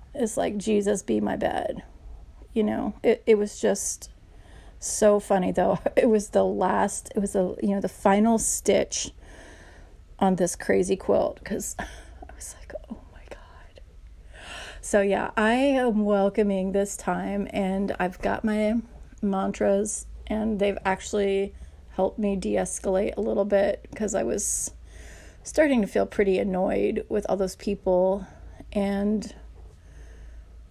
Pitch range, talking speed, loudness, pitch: 190-215 Hz, 140 wpm, -25 LUFS, 200 Hz